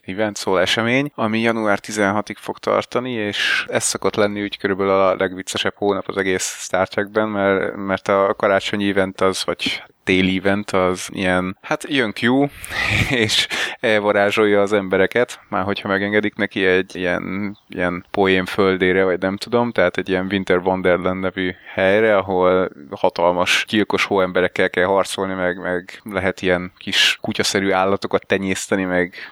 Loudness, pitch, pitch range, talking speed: -19 LUFS, 95 Hz, 95-105 Hz, 145 wpm